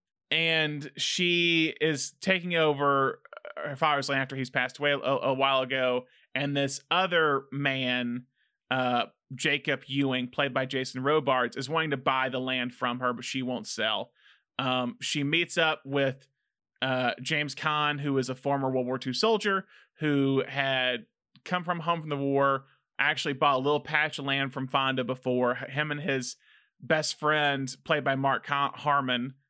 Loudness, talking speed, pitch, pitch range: -28 LUFS, 165 wpm, 135 Hz, 130-150 Hz